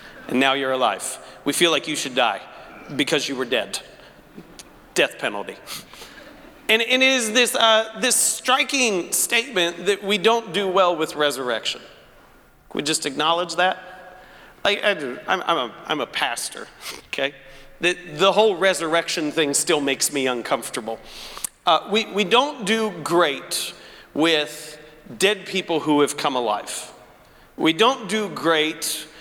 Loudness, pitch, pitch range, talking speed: -21 LUFS, 180 Hz, 150-215 Hz, 145 wpm